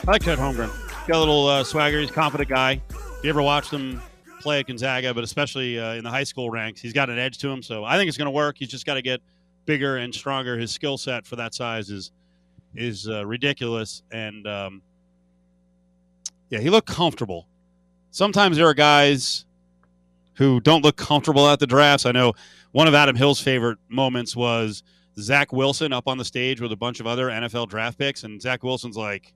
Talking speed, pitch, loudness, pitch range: 215 wpm, 125 Hz, -21 LUFS, 110-145 Hz